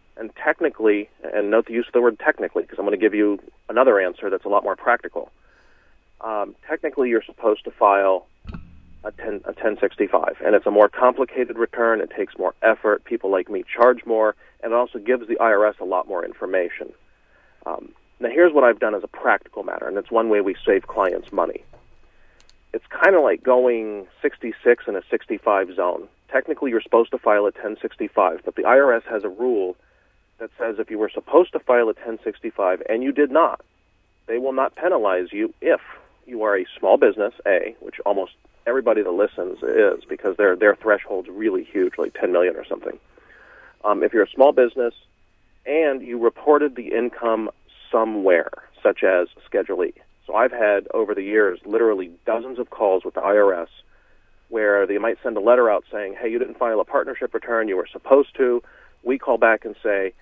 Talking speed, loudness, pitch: 195 wpm, -20 LUFS, 175 Hz